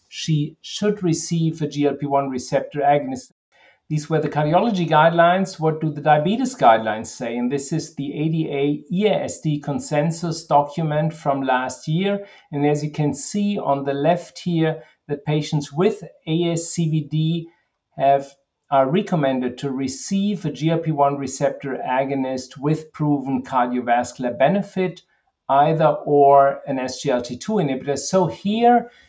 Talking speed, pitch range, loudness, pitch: 130 wpm, 140-170 Hz, -21 LUFS, 150 Hz